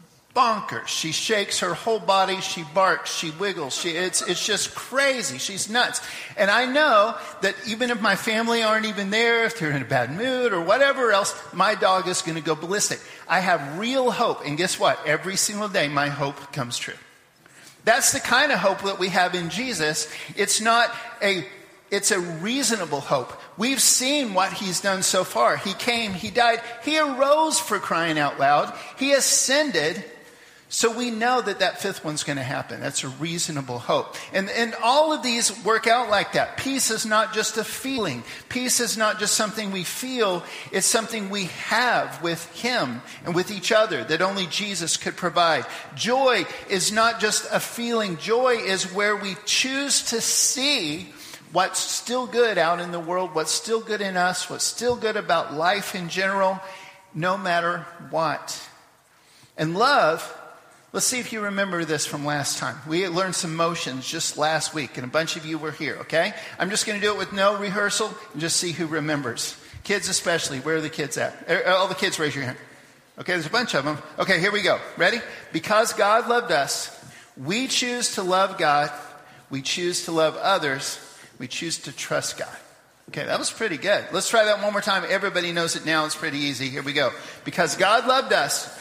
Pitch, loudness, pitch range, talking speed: 195 Hz, -23 LUFS, 165-225 Hz, 195 wpm